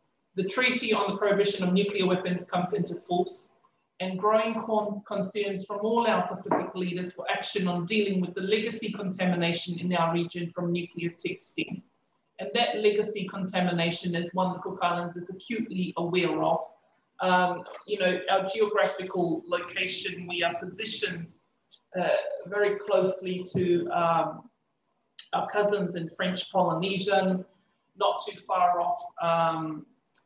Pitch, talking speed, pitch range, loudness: 185 Hz, 145 wpm, 175-205 Hz, -28 LUFS